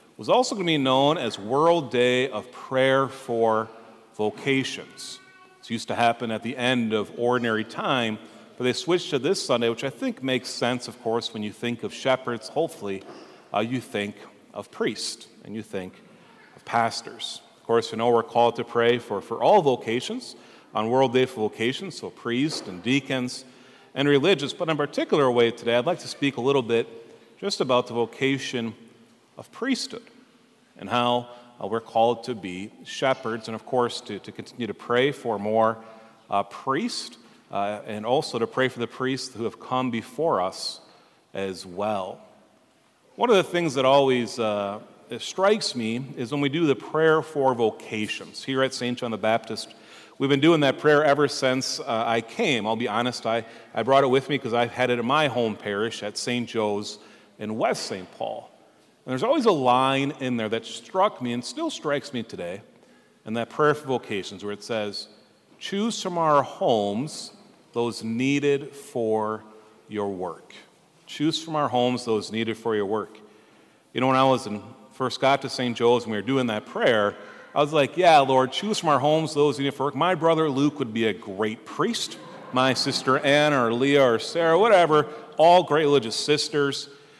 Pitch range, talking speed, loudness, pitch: 115-140 Hz, 190 wpm, -24 LUFS, 125 Hz